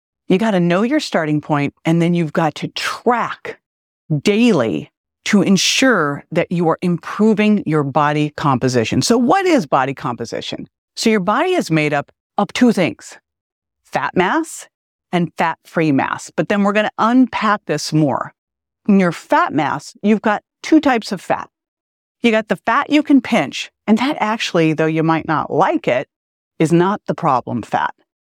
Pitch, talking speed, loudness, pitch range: 190 Hz, 175 wpm, -17 LUFS, 160-225 Hz